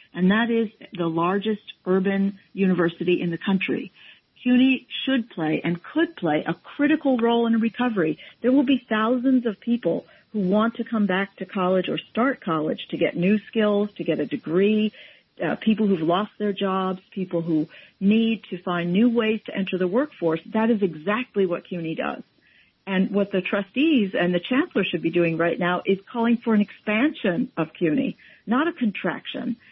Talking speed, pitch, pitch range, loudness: 185 wpm, 200 Hz, 180-235 Hz, -23 LUFS